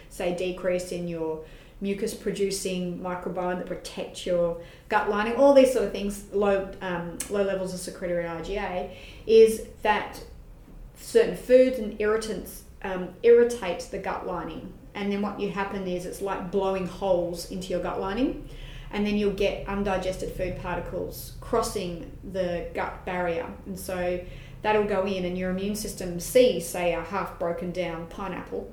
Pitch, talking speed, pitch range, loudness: 185 Hz, 160 wpm, 180-205 Hz, -27 LUFS